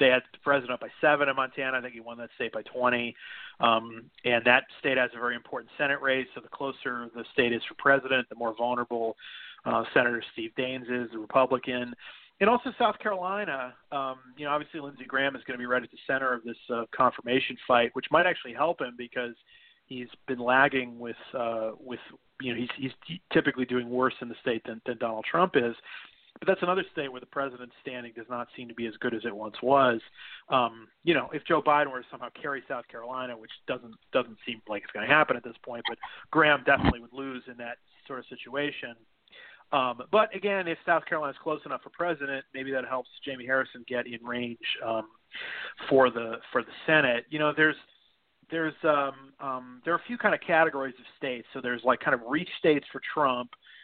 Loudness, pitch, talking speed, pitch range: -28 LUFS, 130 Hz, 215 wpm, 120-145 Hz